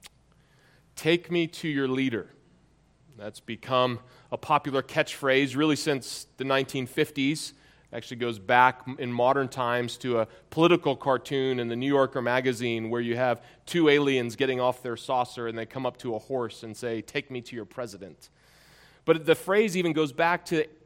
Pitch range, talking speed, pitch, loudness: 125-150 Hz, 175 wpm, 130 Hz, -27 LUFS